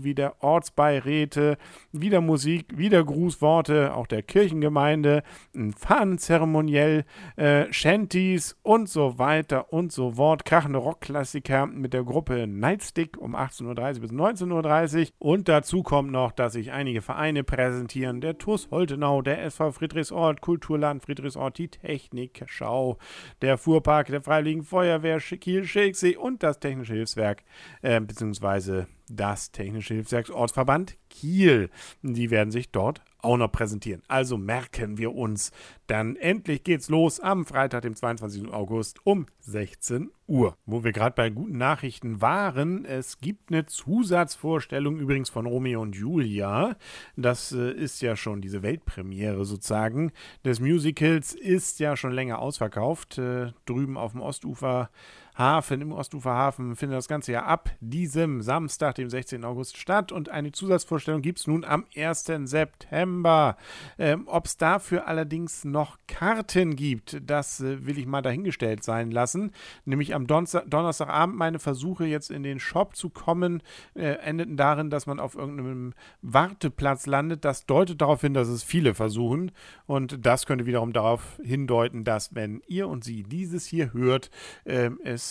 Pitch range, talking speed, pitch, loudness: 125-160 Hz, 145 wpm, 140 Hz, -26 LUFS